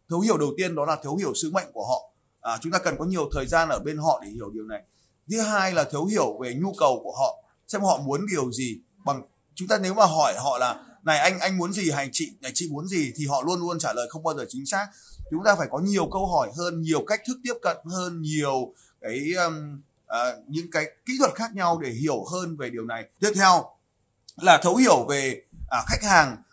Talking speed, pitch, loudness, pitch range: 250 wpm, 165 Hz, -24 LUFS, 145-195 Hz